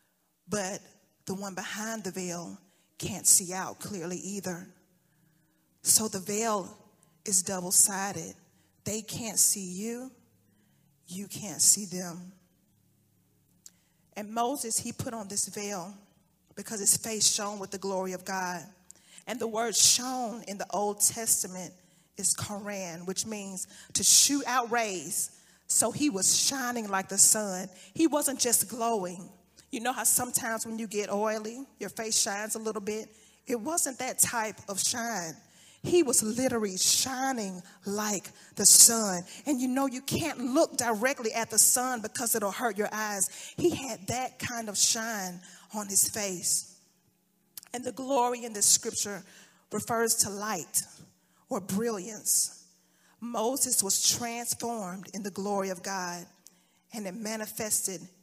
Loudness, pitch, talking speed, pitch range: -27 LUFS, 205 Hz, 145 wpm, 185-230 Hz